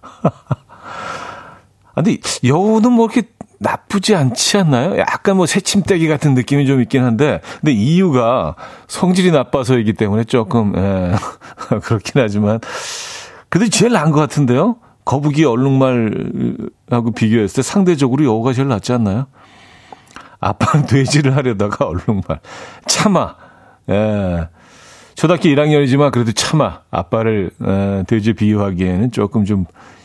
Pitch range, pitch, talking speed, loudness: 110-150 Hz, 125 Hz, 290 characters per minute, -15 LUFS